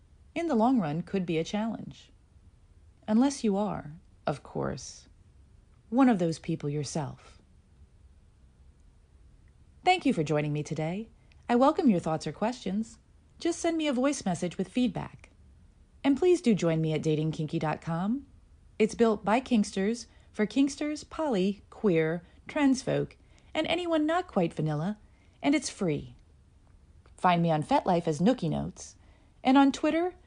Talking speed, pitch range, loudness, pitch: 145 wpm, 150-255 Hz, -29 LUFS, 185 Hz